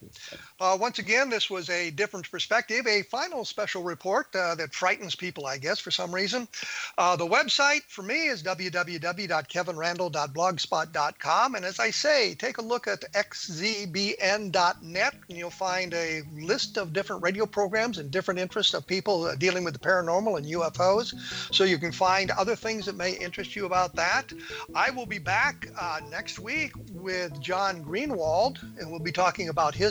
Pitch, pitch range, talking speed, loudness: 185 Hz, 175-205 Hz, 170 wpm, -27 LUFS